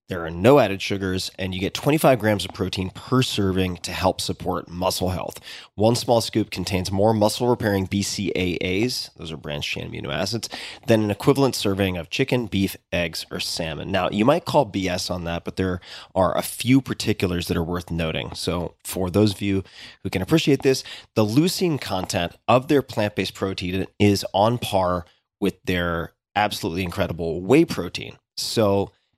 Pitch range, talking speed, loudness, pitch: 90-115 Hz, 180 wpm, -23 LUFS, 100 Hz